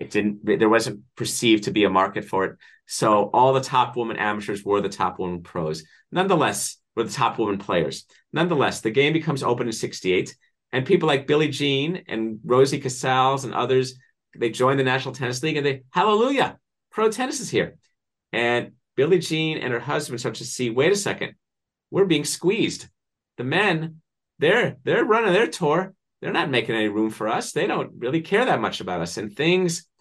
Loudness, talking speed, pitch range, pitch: -22 LUFS, 195 wpm, 115-160 Hz, 130 Hz